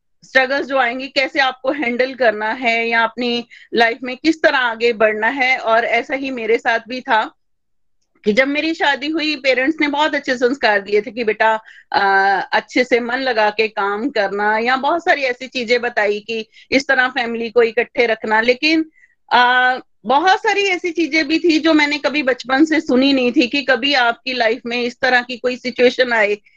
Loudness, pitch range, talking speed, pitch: -16 LUFS, 230-280 Hz, 190 wpm, 250 Hz